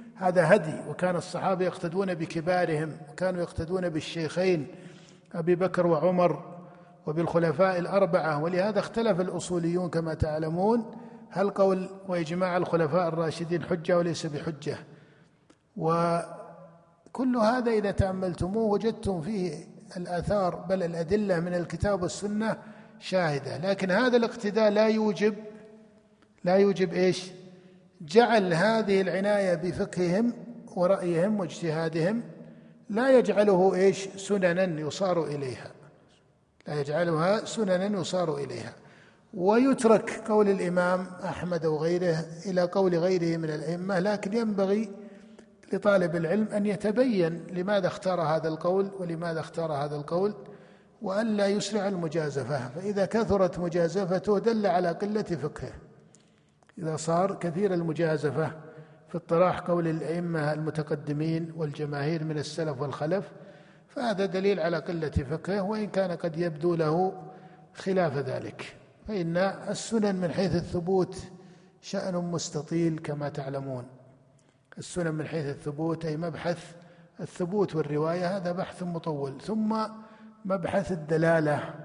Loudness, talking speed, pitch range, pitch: -28 LUFS, 110 wpm, 165-200 Hz, 180 Hz